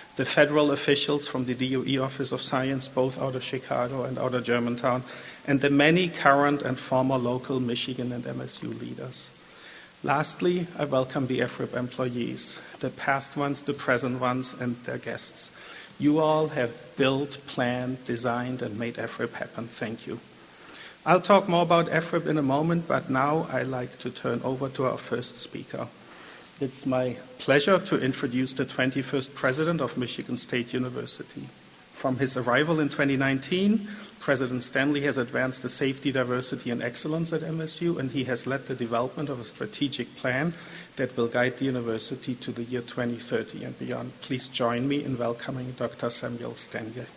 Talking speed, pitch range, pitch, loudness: 165 wpm, 125-145 Hz, 130 Hz, -27 LUFS